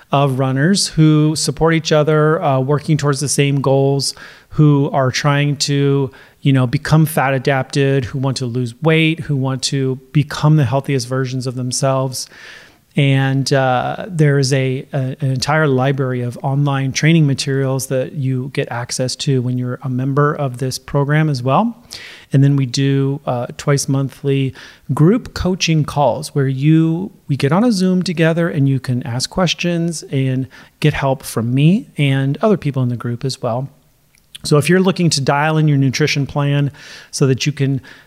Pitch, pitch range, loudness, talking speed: 140 Hz, 135-150 Hz, -16 LUFS, 175 wpm